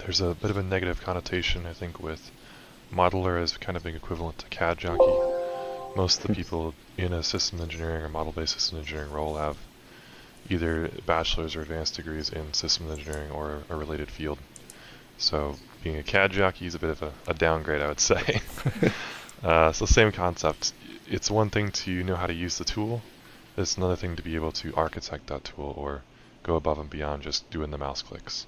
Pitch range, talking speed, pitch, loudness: 75-95 Hz, 200 wpm, 85 Hz, -28 LUFS